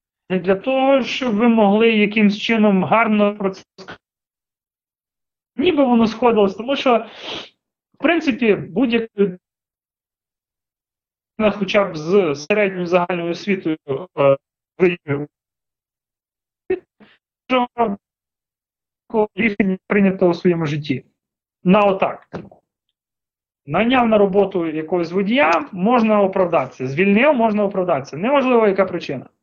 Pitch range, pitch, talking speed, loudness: 180-230 Hz, 205 Hz, 100 wpm, -18 LUFS